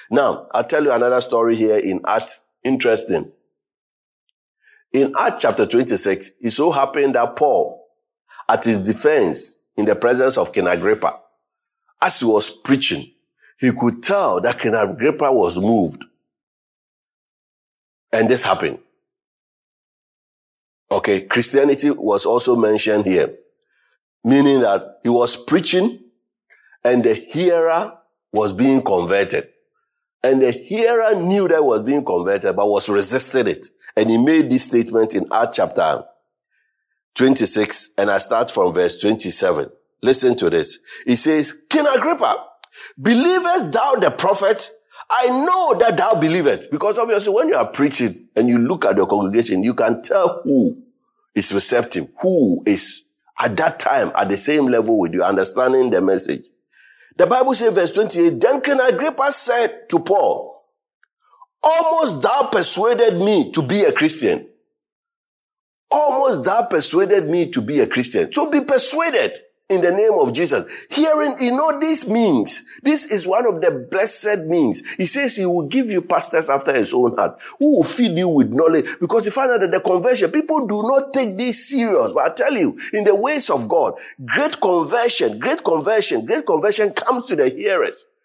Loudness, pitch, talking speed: -15 LUFS, 250 Hz, 155 wpm